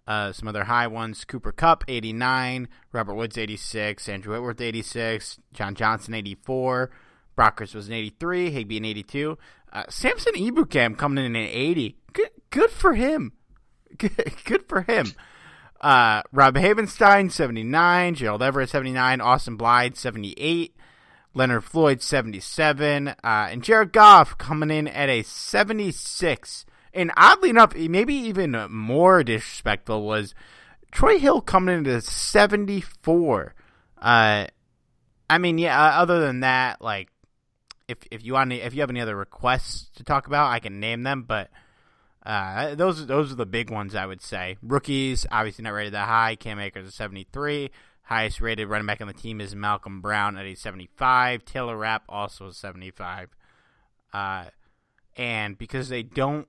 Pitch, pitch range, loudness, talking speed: 120 Hz, 110-150 Hz, -22 LUFS, 160 wpm